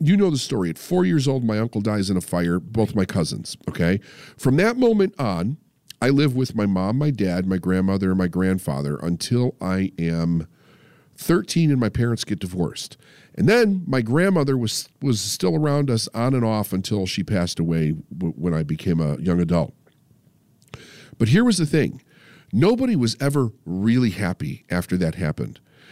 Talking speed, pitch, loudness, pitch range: 180 wpm, 115 Hz, -22 LUFS, 90-145 Hz